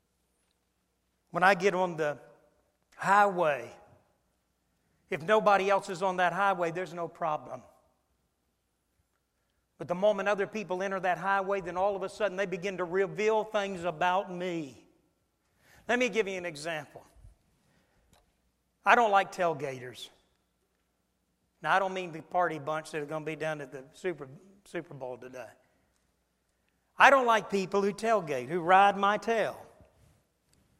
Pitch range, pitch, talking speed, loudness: 140-195 Hz, 180 Hz, 145 wpm, -29 LUFS